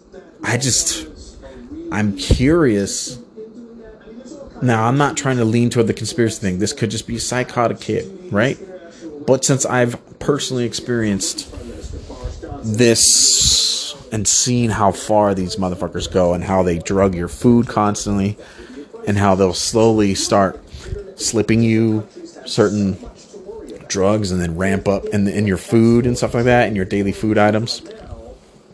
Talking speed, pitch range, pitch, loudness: 145 wpm, 100-125 Hz, 110 Hz, -17 LUFS